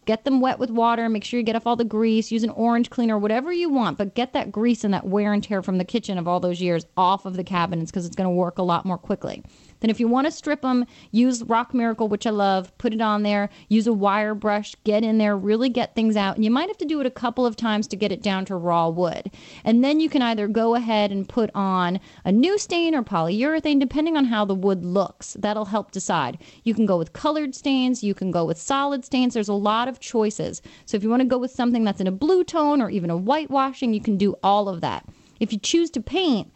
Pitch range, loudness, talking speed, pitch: 195-250 Hz, -22 LUFS, 270 wpm, 220 Hz